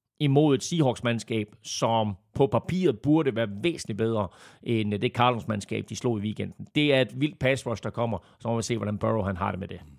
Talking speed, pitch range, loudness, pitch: 210 wpm, 105-130 Hz, -27 LUFS, 115 Hz